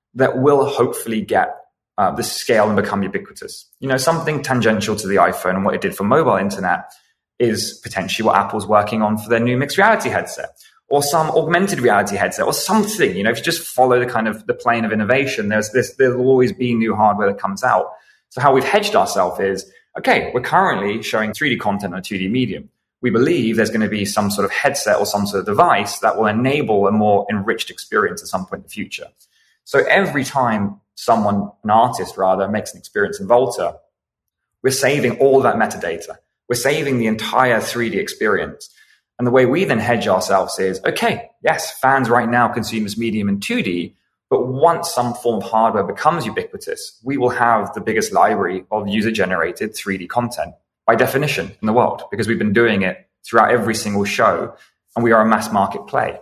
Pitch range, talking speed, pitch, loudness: 105-135 Hz, 205 wpm, 115 Hz, -17 LUFS